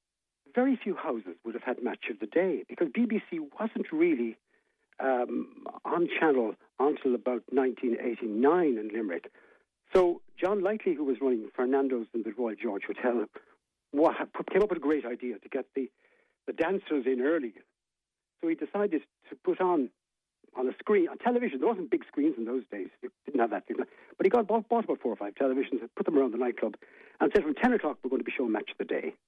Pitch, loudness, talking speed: 190 Hz, -30 LUFS, 205 wpm